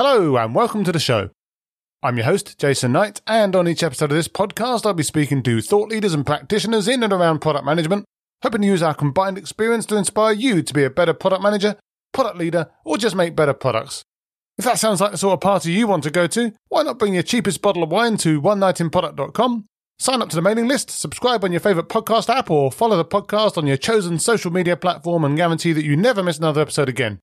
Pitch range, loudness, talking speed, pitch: 160-215 Hz, -19 LUFS, 235 wpm, 190 Hz